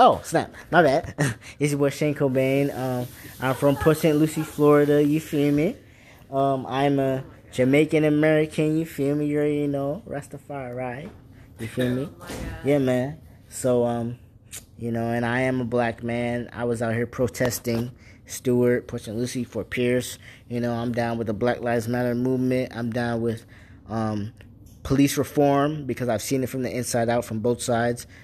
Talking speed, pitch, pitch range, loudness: 185 wpm, 125 Hz, 115-140 Hz, -24 LUFS